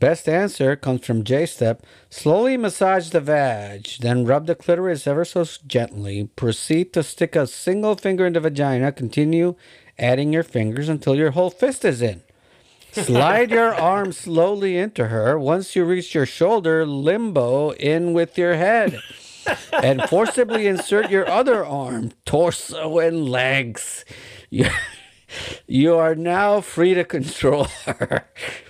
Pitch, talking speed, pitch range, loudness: 160 Hz, 140 wpm, 135-180 Hz, -20 LUFS